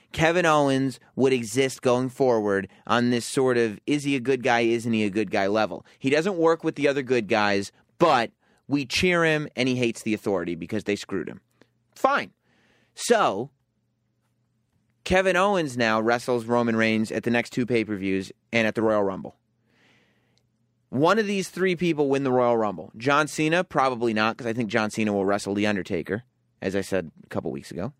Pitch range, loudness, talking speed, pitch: 110-135 Hz, -24 LUFS, 195 wpm, 120 Hz